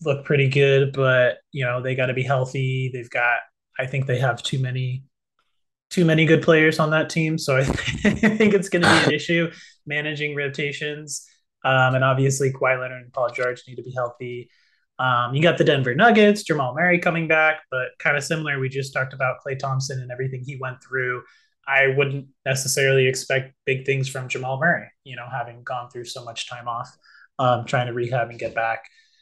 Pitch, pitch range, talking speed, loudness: 135 Hz, 130-155 Hz, 205 wpm, -21 LUFS